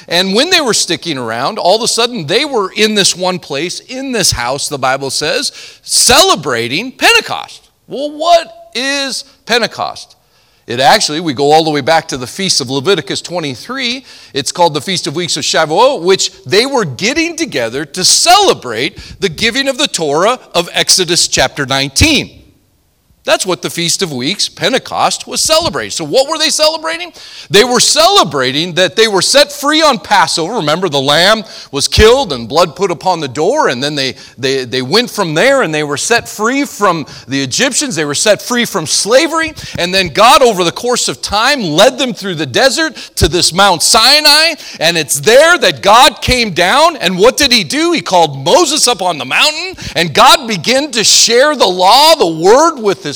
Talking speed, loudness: 190 wpm, -10 LUFS